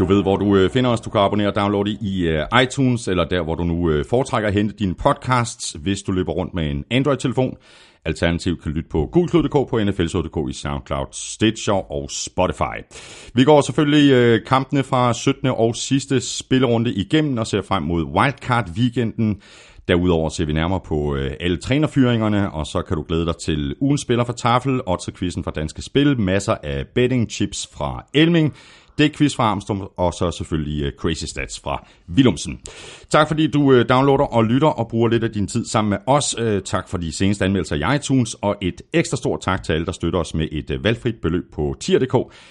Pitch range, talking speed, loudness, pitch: 85-125 Hz, 195 wpm, -20 LUFS, 100 Hz